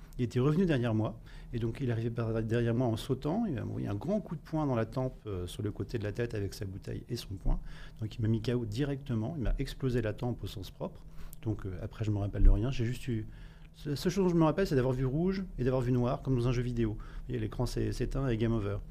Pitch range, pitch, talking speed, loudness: 110-135 Hz, 120 Hz, 290 wpm, -33 LUFS